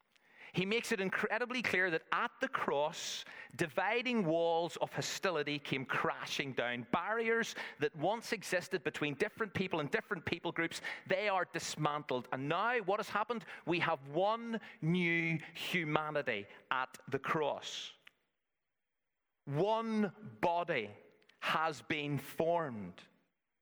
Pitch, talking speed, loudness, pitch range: 170 Hz, 120 wpm, -36 LUFS, 150-210 Hz